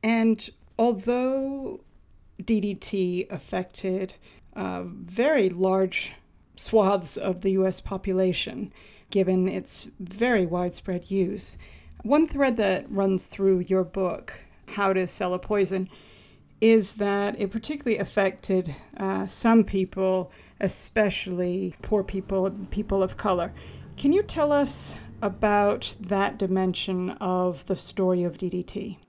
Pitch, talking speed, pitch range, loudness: 195 Hz, 115 wpm, 185-210 Hz, -26 LUFS